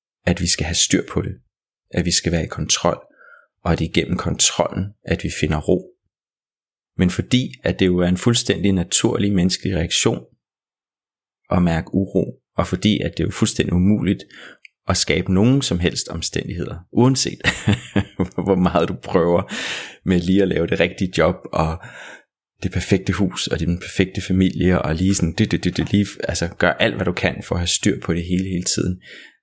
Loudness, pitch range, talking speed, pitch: -20 LUFS, 85-100 Hz, 195 wpm, 90 Hz